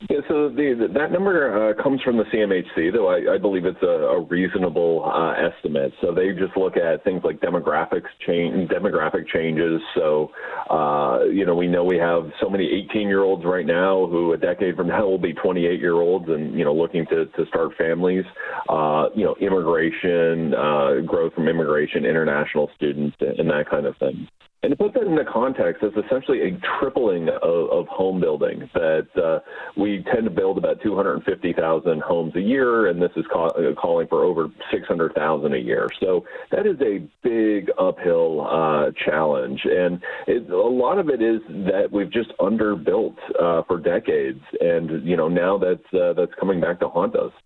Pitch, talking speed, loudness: 145 Hz, 180 wpm, -21 LUFS